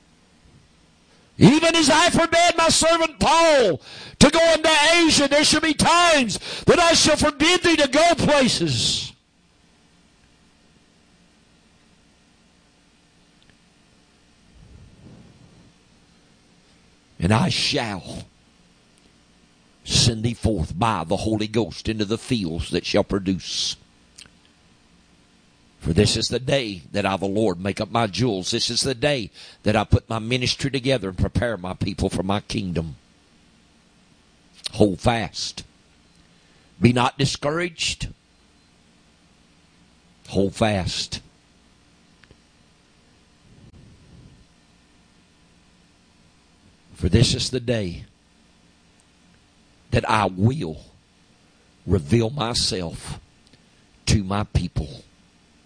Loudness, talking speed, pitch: -20 LUFS, 95 wpm, 105 Hz